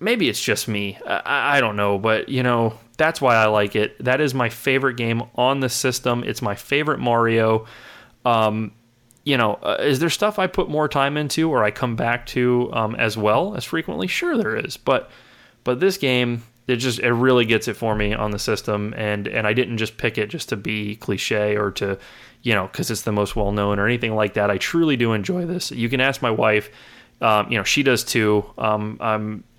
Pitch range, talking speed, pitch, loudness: 105-130 Hz, 225 wpm, 115 Hz, -21 LUFS